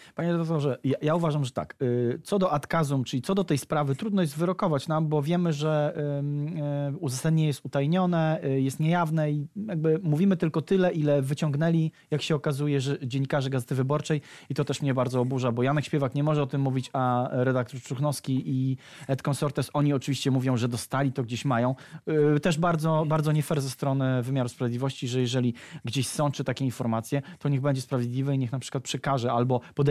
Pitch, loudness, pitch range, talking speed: 145 Hz, -27 LUFS, 130-155 Hz, 190 wpm